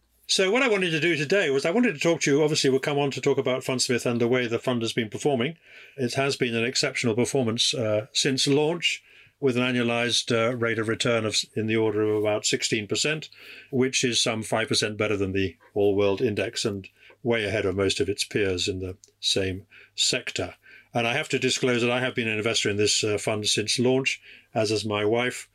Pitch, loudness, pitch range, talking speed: 120 Hz, -24 LUFS, 110-135 Hz, 225 wpm